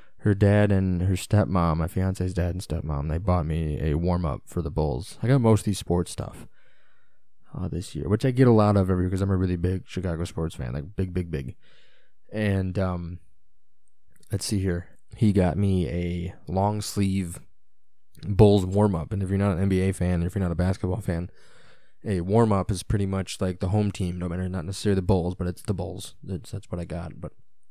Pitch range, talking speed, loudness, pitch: 85-100 Hz, 215 wpm, -25 LUFS, 95 Hz